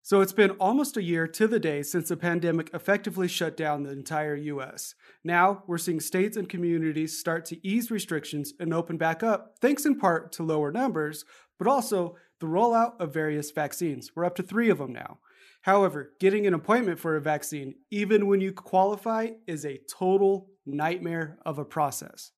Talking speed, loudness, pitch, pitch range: 190 wpm, -27 LUFS, 175 Hz, 155-200 Hz